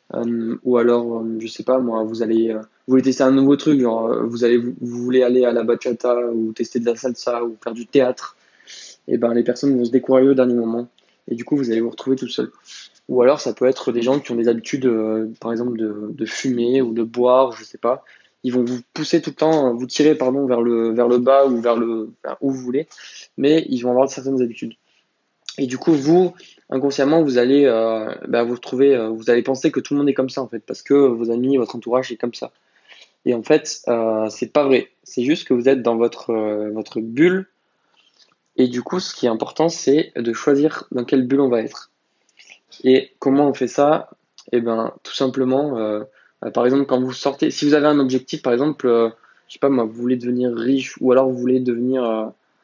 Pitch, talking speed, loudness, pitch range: 125 Hz, 240 wpm, -19 LUFS, 115-135 Hz